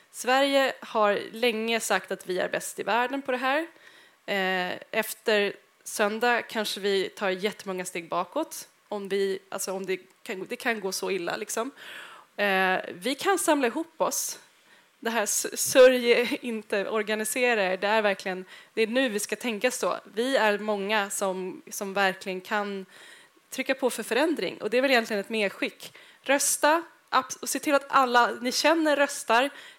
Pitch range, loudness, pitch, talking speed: 200-265 Hz, -26 LUFS, 225 Hz, 160 wpm